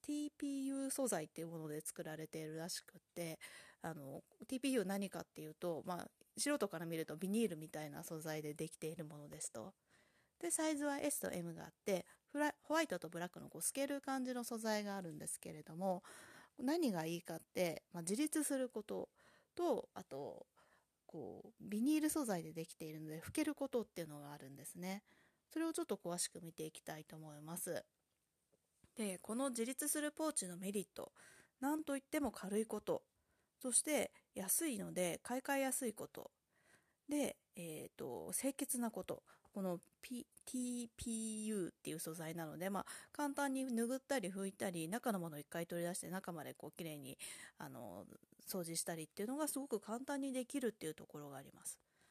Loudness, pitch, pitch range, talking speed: -43 LUFS, 200 Hz, 165-270 Hz, 365 characters per minute